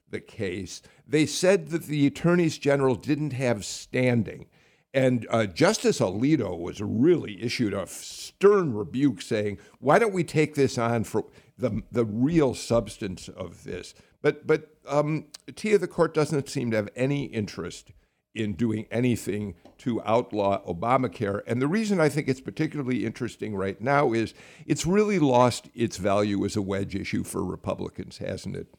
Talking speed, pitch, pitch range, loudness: 160 wpm, 125 Hz, 105-150 Hz, -26 LUFS